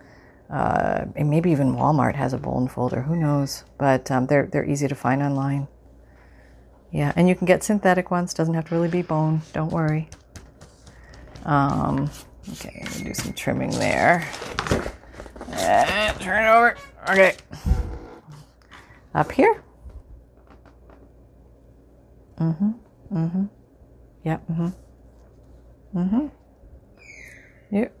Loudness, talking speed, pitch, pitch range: -22 LUFS, 120 wpm, 155 Hz, 135-180 Hz